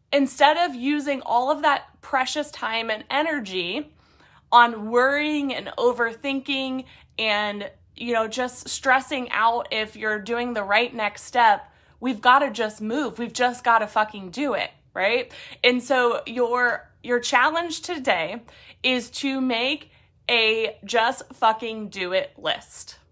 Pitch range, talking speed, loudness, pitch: 225-275 Hz, 145 wpm, -23 LUFS, 245 Hz